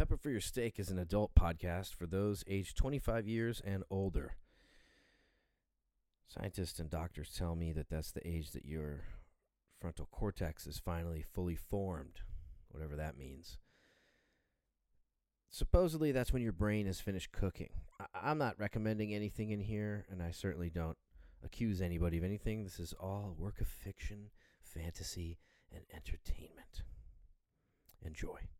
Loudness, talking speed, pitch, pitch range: -41 LUFS, 145 wpm, 90 Hz, 80-105 Hz